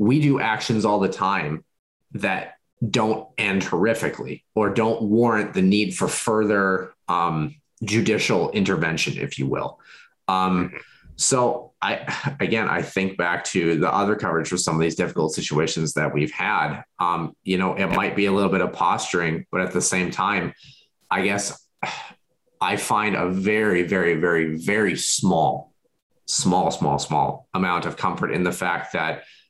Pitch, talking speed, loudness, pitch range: 100 Hz, 160 wpm, -22 LUFS, 90-110 Hz